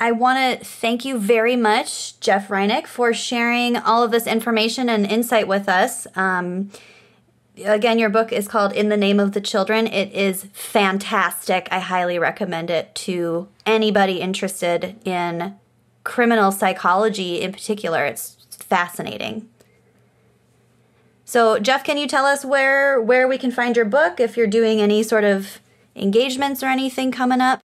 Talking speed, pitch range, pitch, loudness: 155 wpm, 195-240 Hz, 220 Hz, -19 LUFS